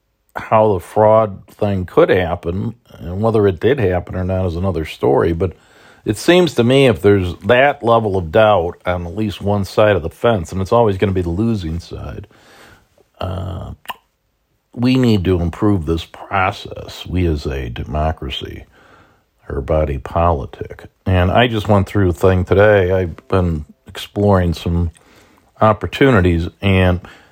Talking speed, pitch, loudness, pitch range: 160 wpm, 95 Hz, -16 LUFS, 85-105 Hz